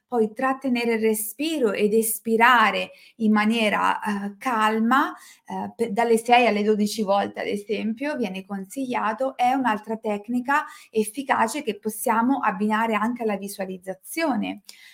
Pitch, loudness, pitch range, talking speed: 220 Hz, -23 LUFS, 210-245 Hz, 120 wpm